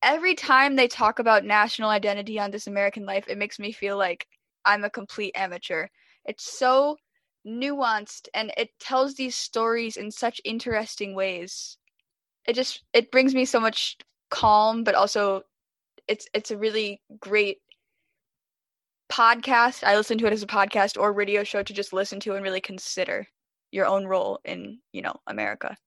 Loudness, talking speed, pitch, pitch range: -24 LUFS, 165 wpm, 215 Hz, 200-245 Hz